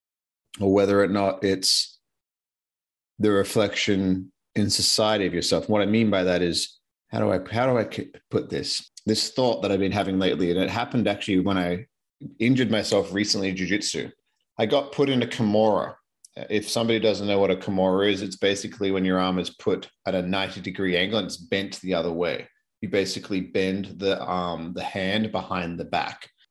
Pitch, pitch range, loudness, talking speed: 100 Hz, 95-105 Hz, -24 LUFS, 190 wpm